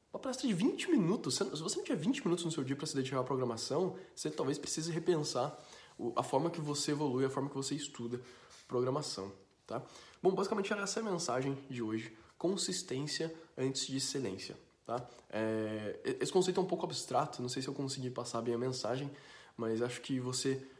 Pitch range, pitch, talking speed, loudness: 125-170 Hz, 135 Hz, 200 wpm, -37 LUFS